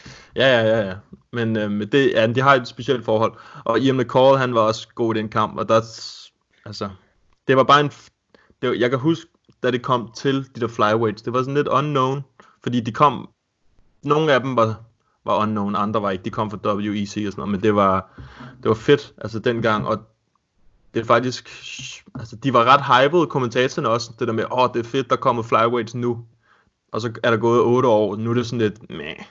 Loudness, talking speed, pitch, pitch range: -20 LUFS, 235 wpm, 115 Hz, 110-130 Hz